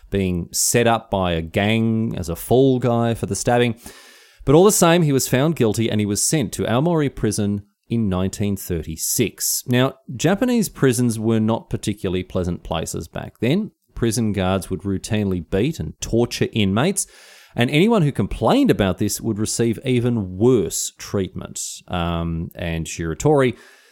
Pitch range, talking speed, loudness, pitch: 95-125 Hz, 155 wpm, -20 LUFS, 110 Hz